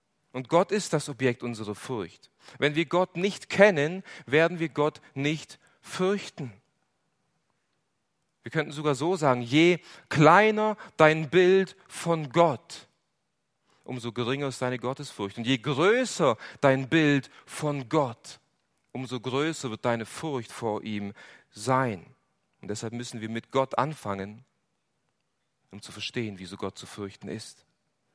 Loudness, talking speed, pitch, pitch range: -26 LUFS, 135 wpm, 140 Hz, 120-165 Hz